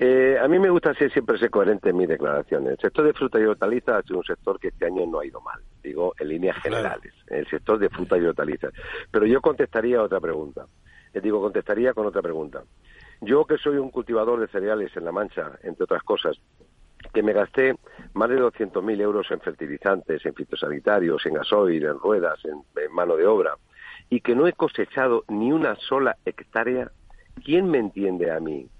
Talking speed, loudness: 200 wpm, -23 LUFS